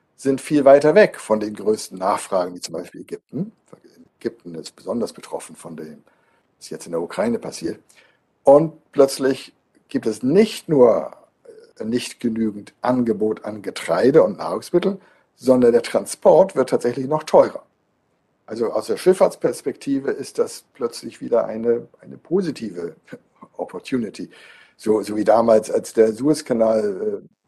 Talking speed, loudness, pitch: 140 wpm, -19 LUFS, 130 Hz